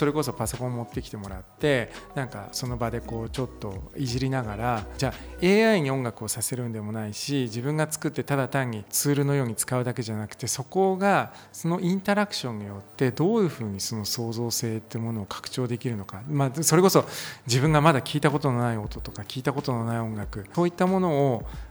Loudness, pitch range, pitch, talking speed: -26 LUFS, 110-145 Hz, 125 Hz, 395 characters per minute